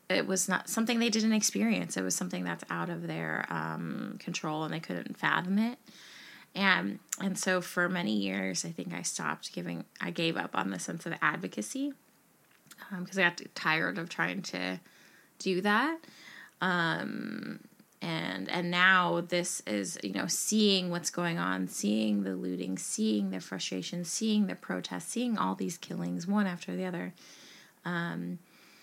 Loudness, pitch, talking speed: -31 LUFS, 175 Hz, 165 wpm